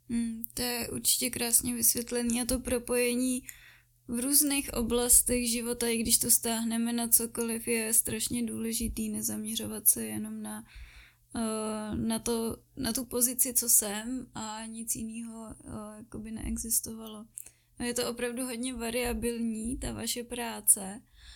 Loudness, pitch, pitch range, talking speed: -28 LUFS, 230 Hz, 220-245 Hz, 125 wpm